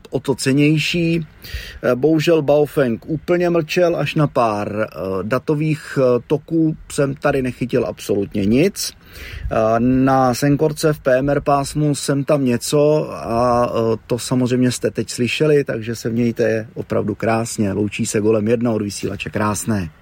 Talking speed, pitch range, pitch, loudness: 130 wpm, 115-150 Hz, 130 Hz, -18 LUFS